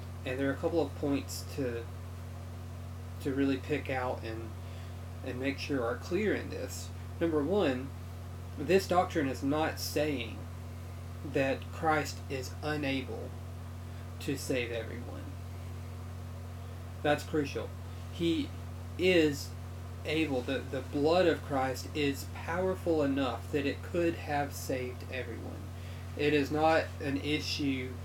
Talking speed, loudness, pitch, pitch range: 125 wpm, -33 LUFS, 90 Hz, 90-130 Hz